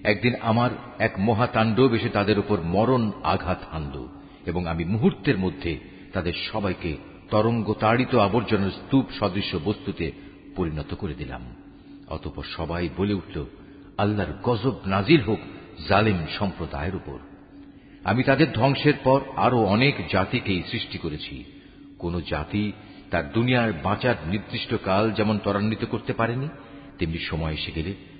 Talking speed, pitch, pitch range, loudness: 125 wpm, 105 Hz, 90-120 Hz, -24 LUFS